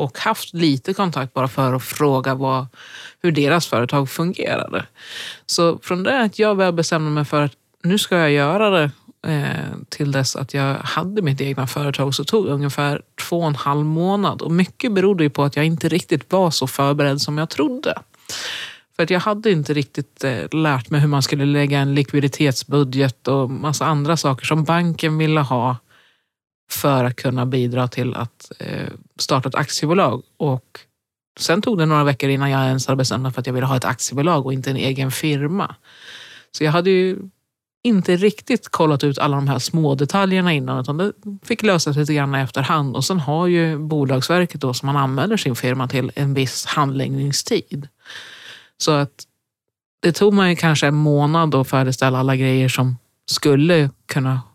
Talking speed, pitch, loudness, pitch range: 185 wpm, 145 Hz, -19 LUFS, 135-170 Hz